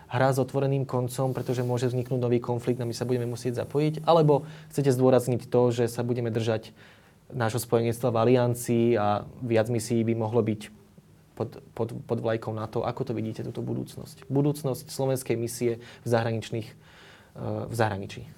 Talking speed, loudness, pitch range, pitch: 165 wpm, -27 LUFS, 115-130 Hz, 120 Hz